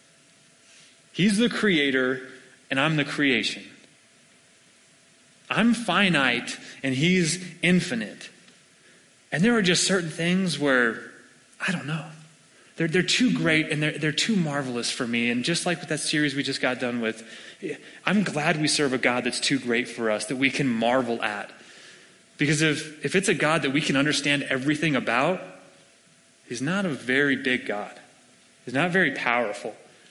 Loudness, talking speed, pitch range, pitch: -24 LUFS, 165 wpm, 130-175 Hz, 150 Hz